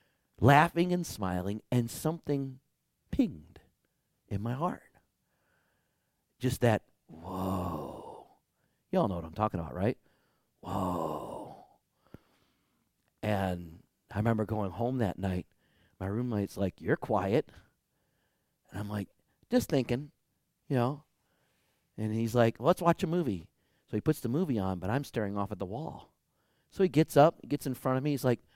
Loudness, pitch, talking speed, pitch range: -31 LUFS, 115 Hz, 155 wpm, 95-140 Hz